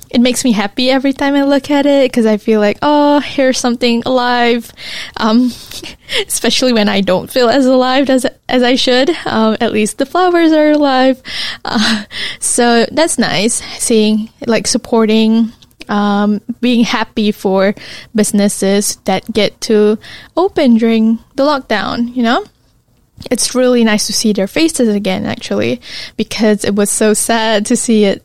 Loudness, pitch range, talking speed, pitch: -12 LUFS, 215-260 Hz, 160 wpm, 235 Hz